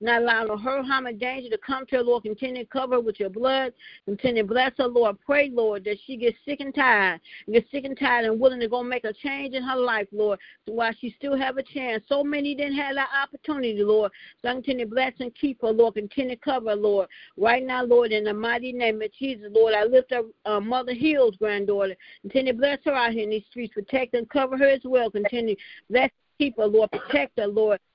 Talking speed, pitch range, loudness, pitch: 245 wpm, 220-265 Hz, -24 LUFS, 245 Hz